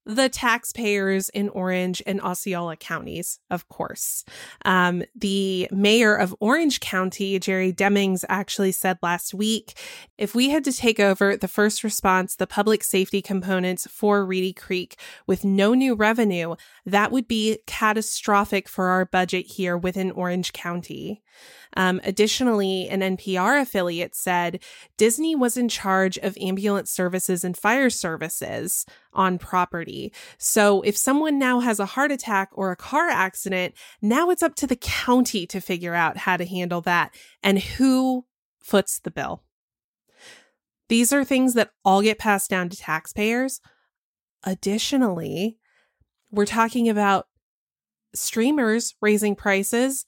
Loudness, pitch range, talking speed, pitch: -22 LUFS, 185-225 Hz, 140 wpm, 200 Hz